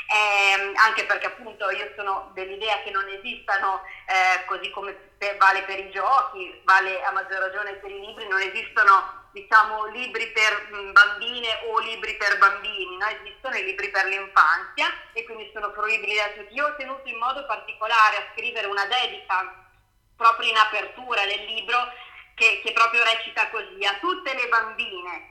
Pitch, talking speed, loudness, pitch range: 210 Hz, 165 wpm, -22 LUFS, 195-225 Hz